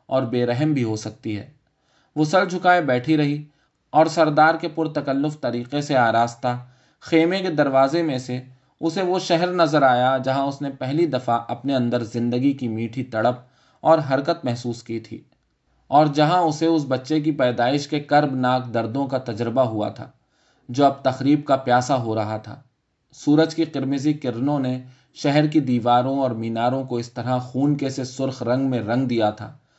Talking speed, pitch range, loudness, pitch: 185 wpm, 125-150 Hz, -21 LUFS, 135 Hz